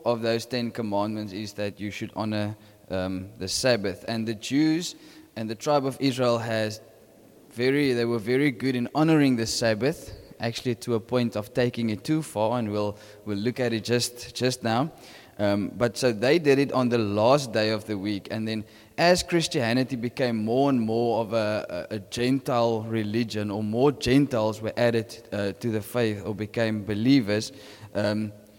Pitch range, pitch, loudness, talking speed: 105-125 Hz, 115 Hz, -26 LUFS, 185 wpm